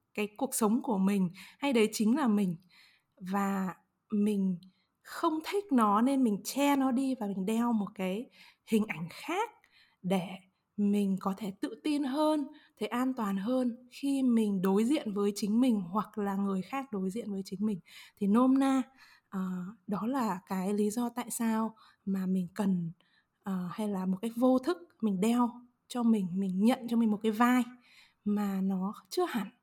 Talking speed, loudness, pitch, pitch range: 180 wpm, -31 LUFS, 215 Hz, 195-250 Hz